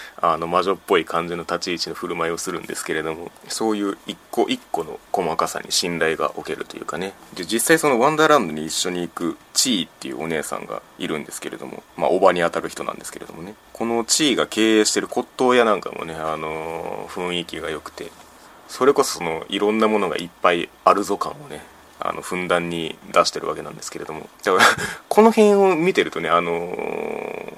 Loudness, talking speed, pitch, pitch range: -21 LUFS, 425 characters per minute, 90 Hz, 85-115 Hz